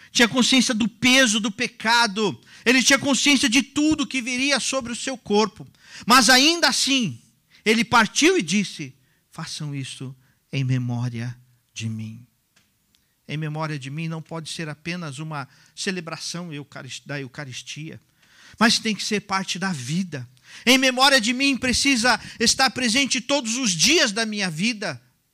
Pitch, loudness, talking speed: 205 Hz, -20 LUFS, 145 wpm